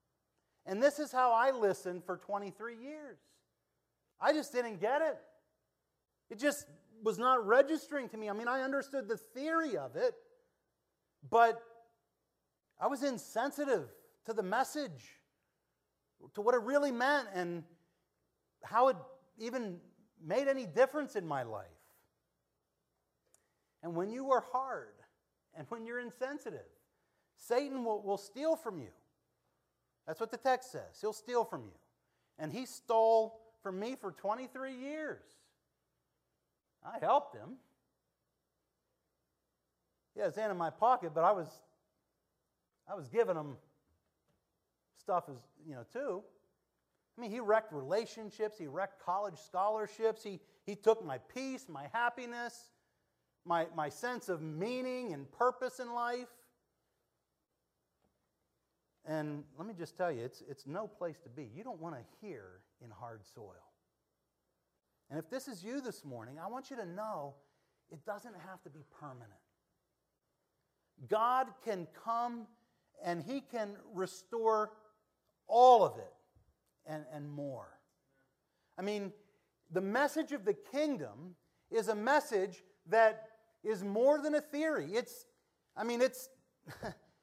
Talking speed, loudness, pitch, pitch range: 135 wpm, -36 LUFS, 220 Hz, 175-255 Hz